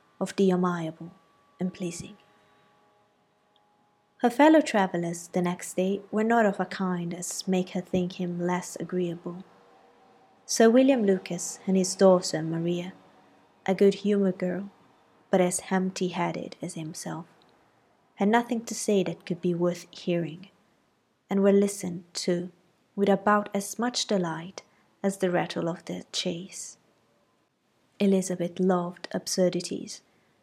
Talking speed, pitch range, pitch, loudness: 130 wpm, 175-195 Hz, 180 Hz, -27 LUFS